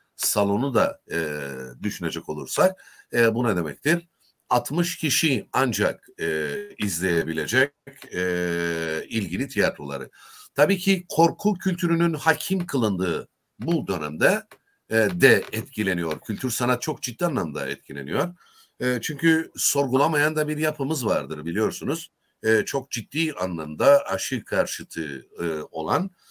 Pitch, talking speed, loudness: 135 Hz, 115 wpm, -24 LUFS